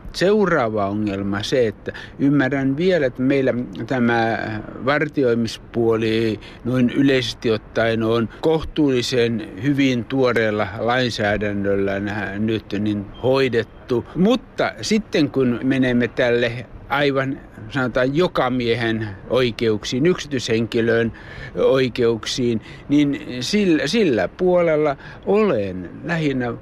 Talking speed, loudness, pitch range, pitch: 90 wpm, -20 LUFS, 110-140 Hz, 120 Hz